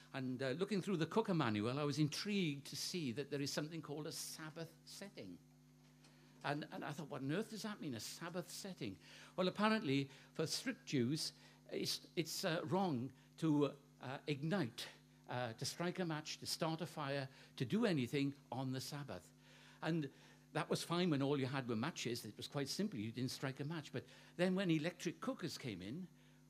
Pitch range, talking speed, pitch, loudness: 135-170 Hz, 195 wpm, 145 Hz, -42 LUFS